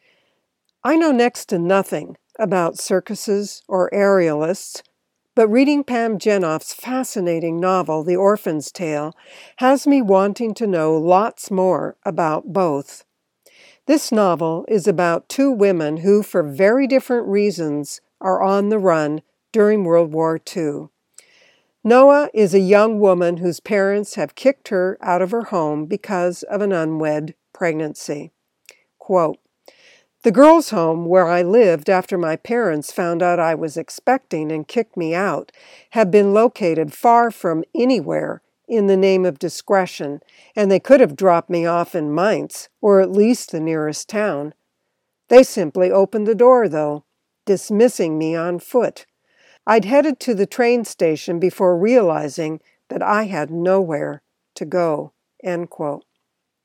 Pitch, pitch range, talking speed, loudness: 190 Hz, 170-225 Hz, 145 wpm, -17 LUFS